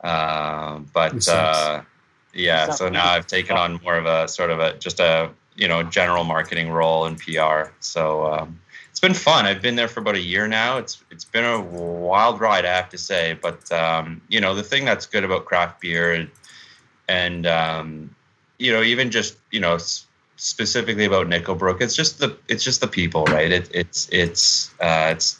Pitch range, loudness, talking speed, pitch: 80-105 Hz, -20 LUFS, 200 wpm, 85 Hz